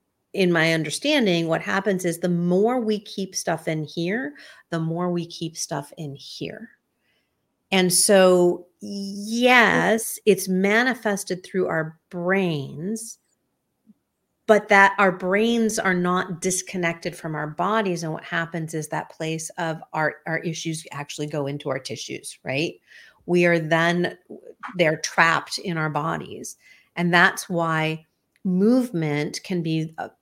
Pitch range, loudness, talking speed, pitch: 160-200 Hz, -22 LUFS, 135 wpm, 175 Hz